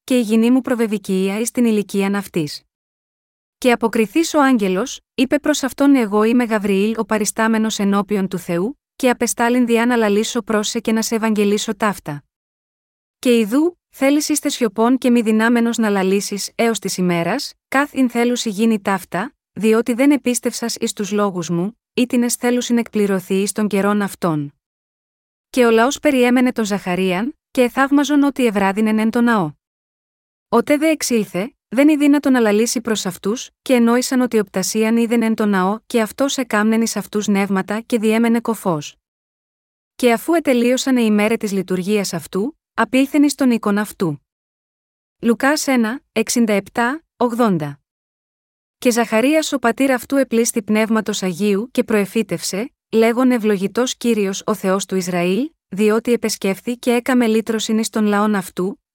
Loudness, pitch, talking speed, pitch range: -17 LUFS, 225 Hz, 155 wpm, 205-245 Hz